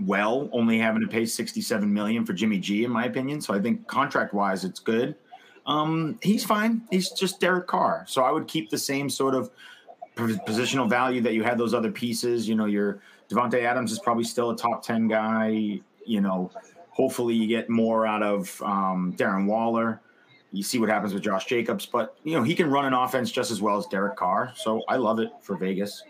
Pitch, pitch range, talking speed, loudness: 120 Hz, 110-160 Hz, 210 wpm, -25 LUFS